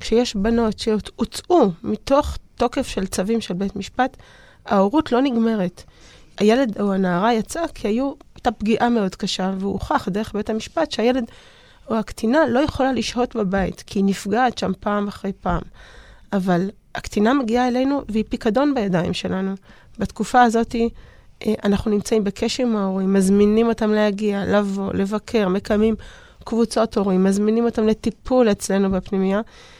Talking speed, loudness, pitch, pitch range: 140 wpm, -21 LUFS, 220 Hz, 200-235 Hz